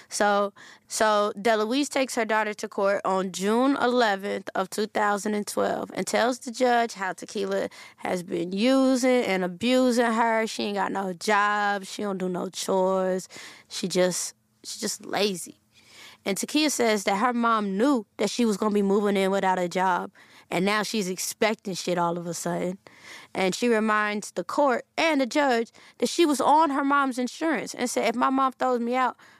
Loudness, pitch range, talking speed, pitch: -25 LUFS, 195-245 Hz, 190 wpm, 215 Hz